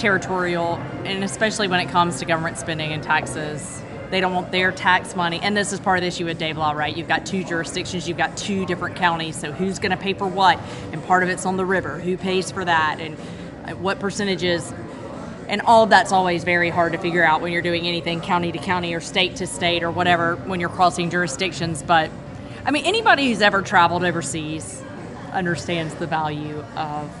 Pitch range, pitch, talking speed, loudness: 160-185 Hz, 175 Hz, 215 wpm, -21 LUFS